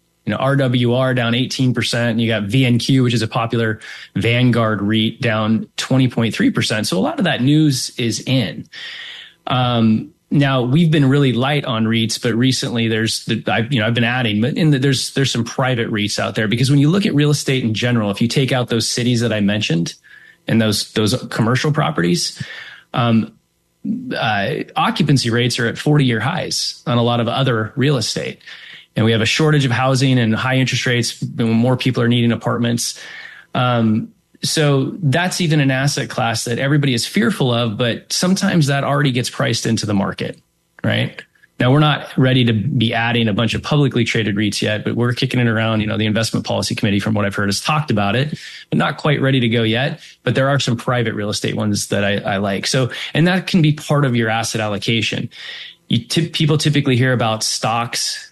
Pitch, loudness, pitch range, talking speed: 120 Hz, -17 LUFS, 115-140 Hz, 210 wpm